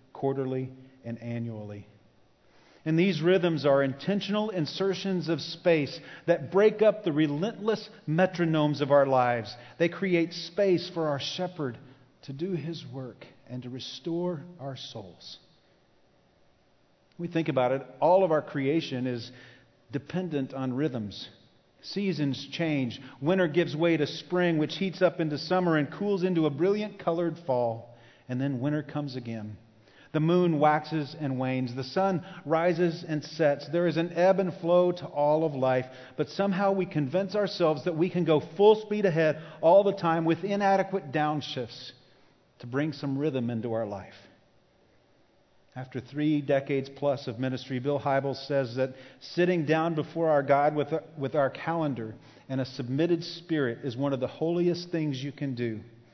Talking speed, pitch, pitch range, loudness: 155 wpm, 150 Hz, 130-170 Hz, -28 LUFS